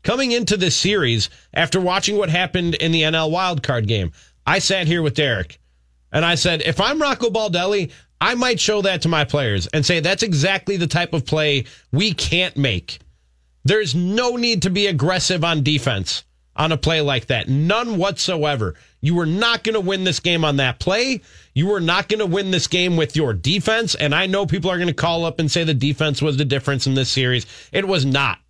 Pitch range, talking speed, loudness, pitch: 140-190 Hz, 215 wpm, -19 LUFS, 165 Hz